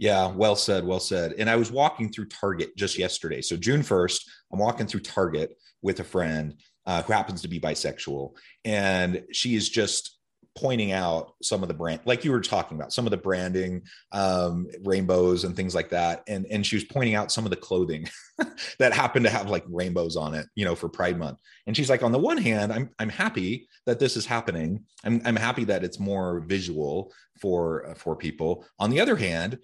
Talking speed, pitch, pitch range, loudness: 215 wpm, 95 Hz, 90-110 Hz, -26 LUFS